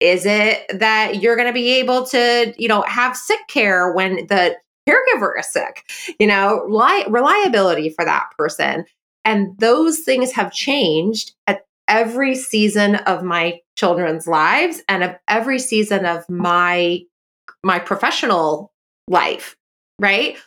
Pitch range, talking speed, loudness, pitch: 180-245 Hz, 140 wpm, -16 LUFS, 210 Hz